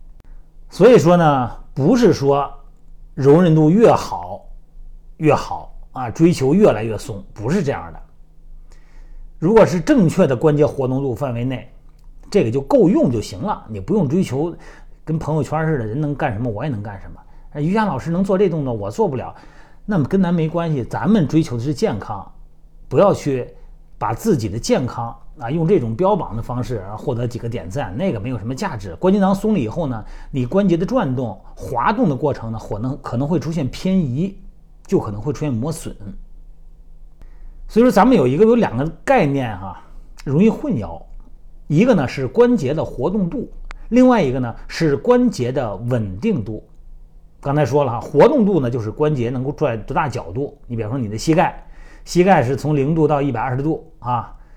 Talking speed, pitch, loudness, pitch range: 275 characters per minute, 145 Hz, -18 LUFS, 120-170 Hz